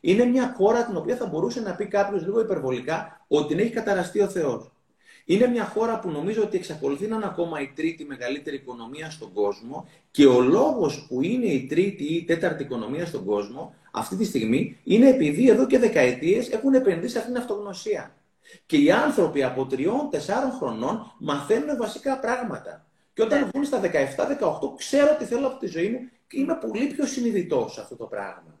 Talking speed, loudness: 190 wpm, -24 LUFS